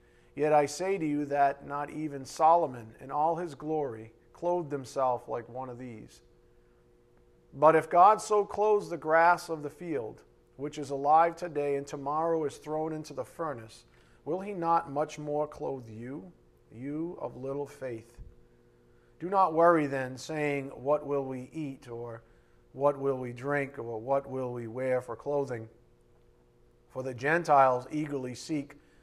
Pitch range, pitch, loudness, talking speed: 115-155 Hz, 140 Hz, -30 LUFS, 160 wpm